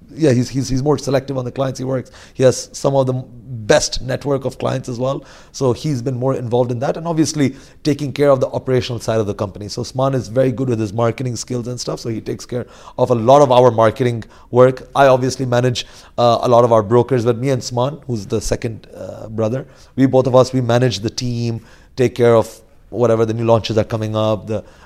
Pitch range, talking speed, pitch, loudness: 115-130 Hz, 240 wpm, 125 Hz, -17 LUFS